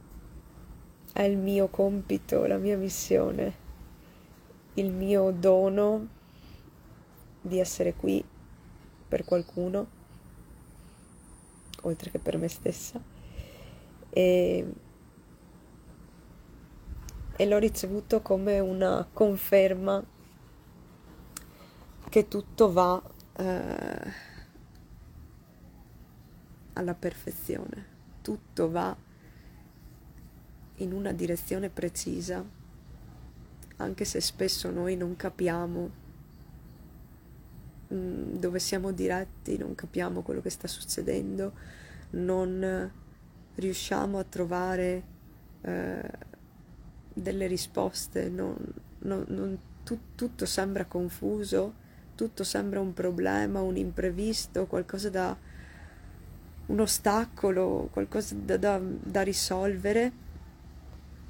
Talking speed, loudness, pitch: 80 wpm, -30 LUFS, 180 Hz